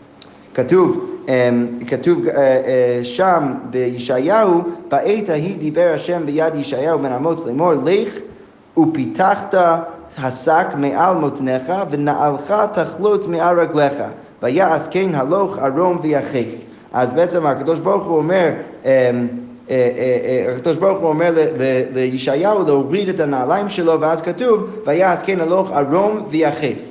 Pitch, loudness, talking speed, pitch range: 160 Hz, -17 LUFS, 105 wpm, 135-185 Hz